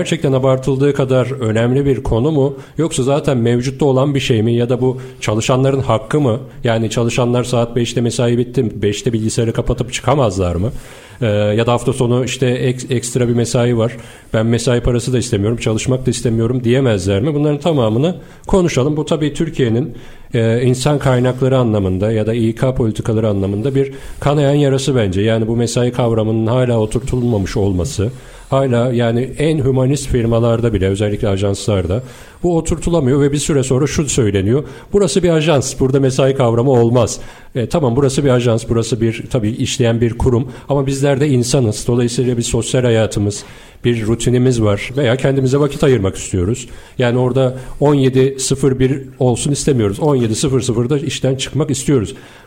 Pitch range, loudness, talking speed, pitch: 115-135 Hz, -15 LUFS, 155 wpm, 125 Hz